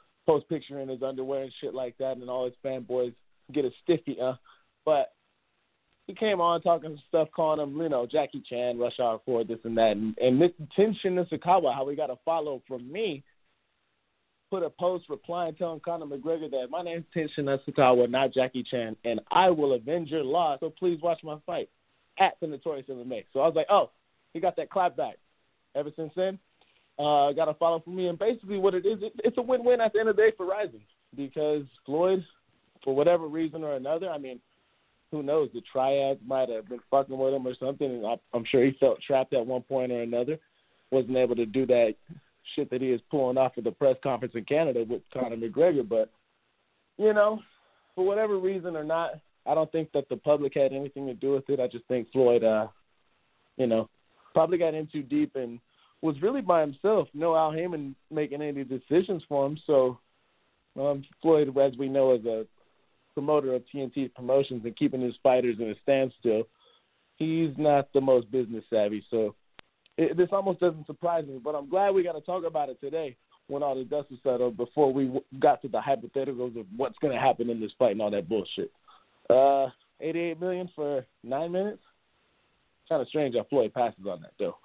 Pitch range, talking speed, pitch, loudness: 125-165 Hz, 210 wpm, 140 Hz, -28 LUFS